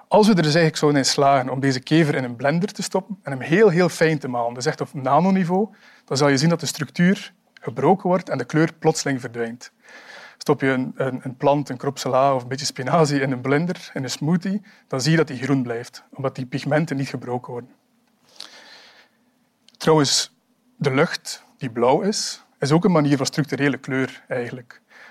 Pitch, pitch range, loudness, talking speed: 150 Hz, 135-190 Hz, -21 LUFS, 205 wpm